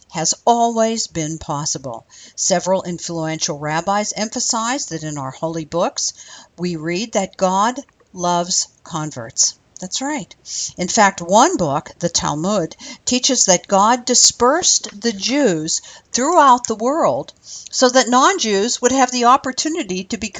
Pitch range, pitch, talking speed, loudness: 170-250 Hz, 205 Hz, 130 wpm, -17 LUFS